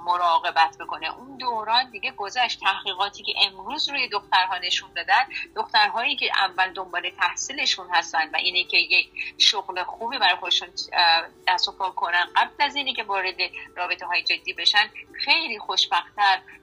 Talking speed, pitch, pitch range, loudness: 150 wpm, 190 Hz, 175-230 Hz, -22 LUFS